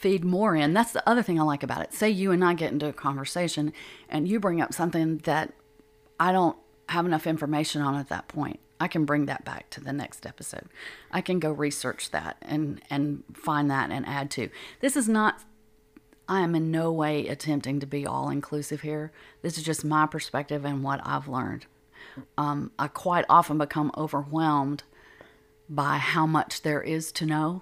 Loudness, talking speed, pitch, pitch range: -27 LUFS, 200 wpm, 150 Hz, 145-165 Hz